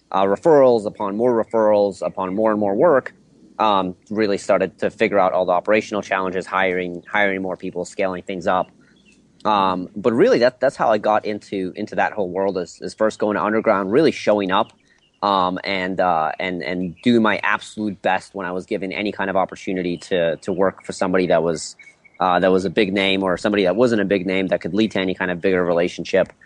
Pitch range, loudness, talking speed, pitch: 90-105 Hz, -20 LUFS, 215 wpm, 95 Hz